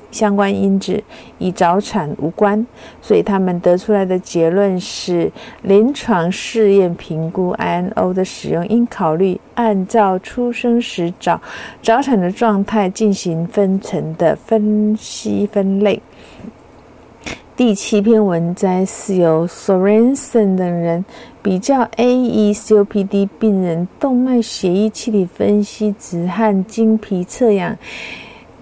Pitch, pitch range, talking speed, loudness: 205 Hz, 185-225 Hz, 200 characters per minute, -16 LUFS